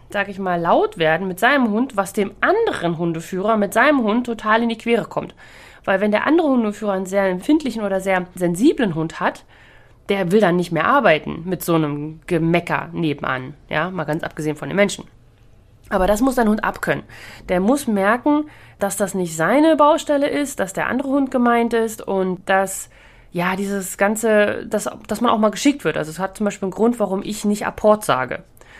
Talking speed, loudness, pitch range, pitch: 200 wpm, -19 LUFS, 175-230 Hz, 200 Hz